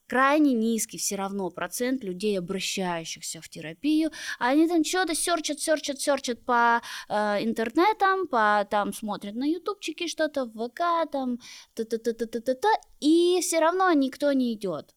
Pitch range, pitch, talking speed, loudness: 210-320 Hz, 255 Hz, 135 wpm, -26 LUFS